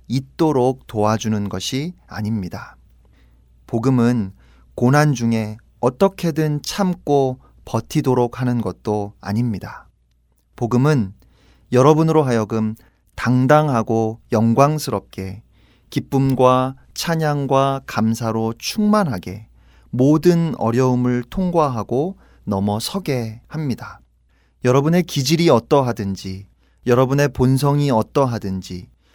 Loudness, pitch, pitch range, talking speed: -19 LUFS, 120 Hz, 105-140 Hz, 230 characters per minute